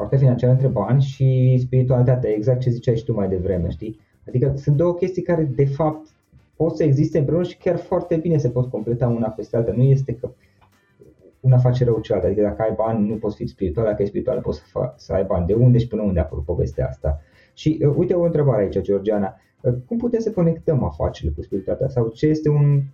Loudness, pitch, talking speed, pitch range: -20 LUFS, 125 Hz, 220 wpm, 110-150 Hz